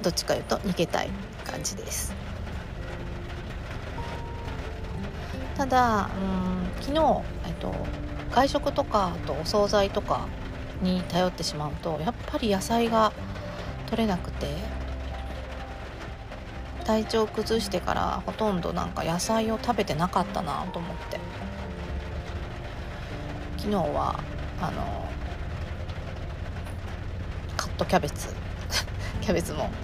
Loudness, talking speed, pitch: -29 LUFS, 200 characters per minute, 95 Hz